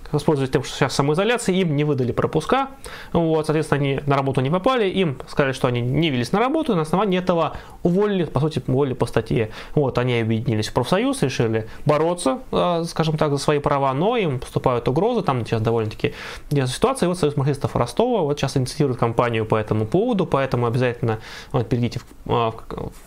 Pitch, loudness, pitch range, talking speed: 145 Hz, -21 LUFS, 125-165 Hz, 185 wpm